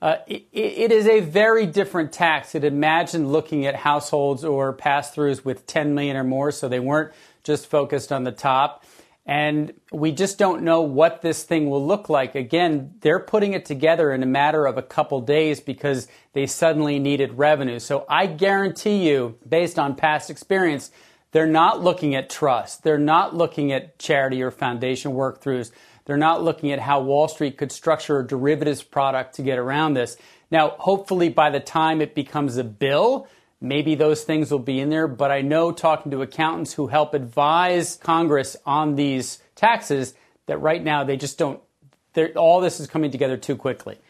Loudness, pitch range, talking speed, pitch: -21 LUFS, 140-160 Hz, 185 wpm, 150 Hz